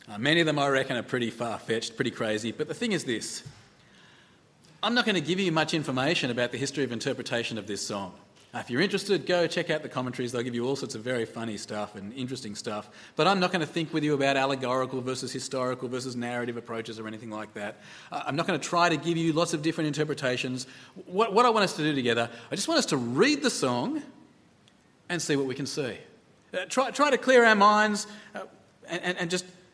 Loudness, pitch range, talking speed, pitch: -27 LUFS, 125-180 Hz, 240 wpm, 145 Hz